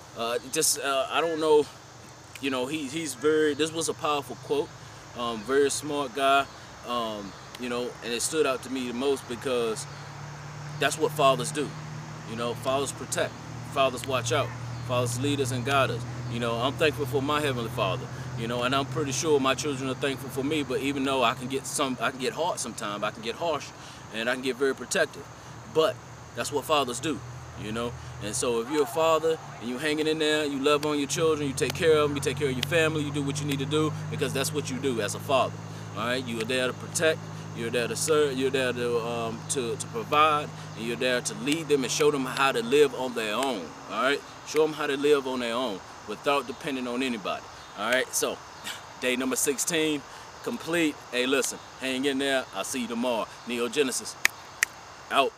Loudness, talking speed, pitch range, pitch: -27 LUFS, 225 wpm, 125-150 Hz, 135 Hz